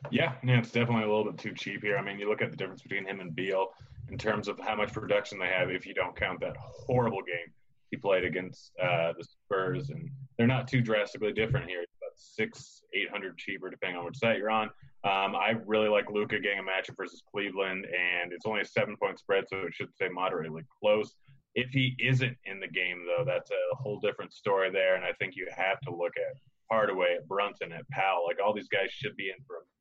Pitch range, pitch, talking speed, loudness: 100-135 Hz, 110 Hz, 240 wpm, -31 LUFS